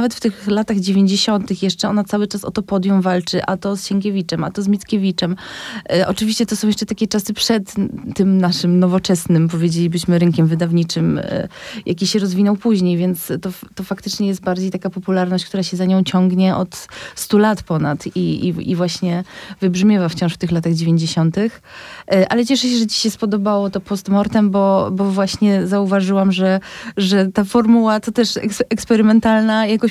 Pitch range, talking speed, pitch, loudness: 185-215 Hz, 180 wpm, 195 Hz, -17 LUFS